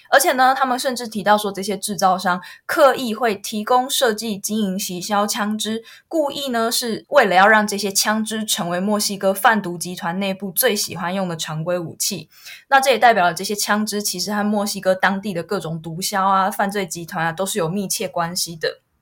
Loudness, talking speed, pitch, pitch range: -19 LUFS, 305 characters per minute, 205 Hz, 185-220 Hz